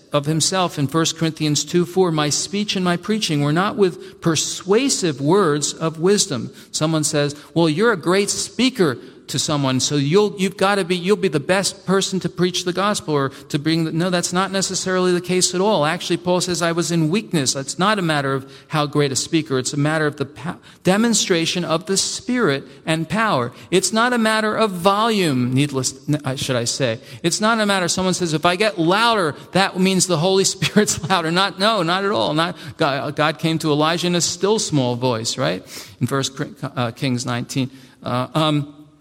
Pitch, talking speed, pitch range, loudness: 170 Hz, 205 wpm, 145-190 Hz, -19 LUFS